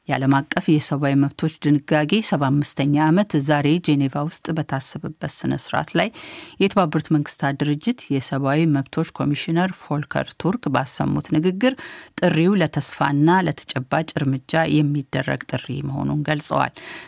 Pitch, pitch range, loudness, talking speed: 150 Hz, 140-165 Hz, -21 LUFS, 110 wpm